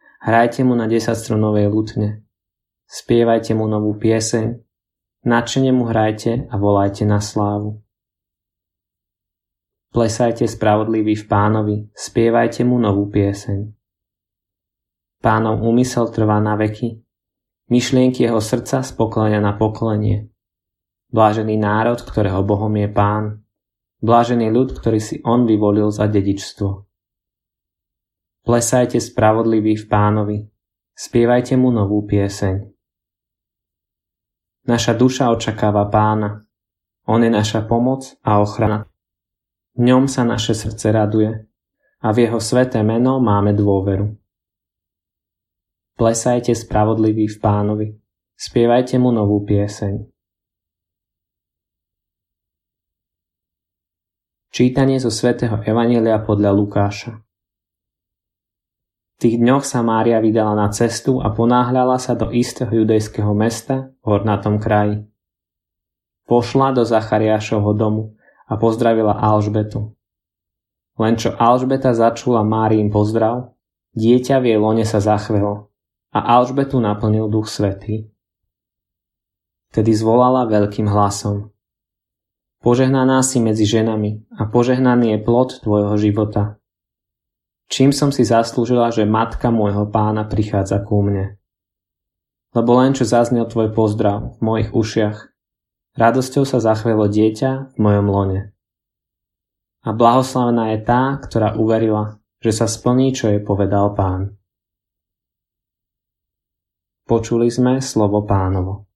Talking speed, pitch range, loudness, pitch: 105 wpm, 100-115 Hz, -17 LUFS, 110 Hz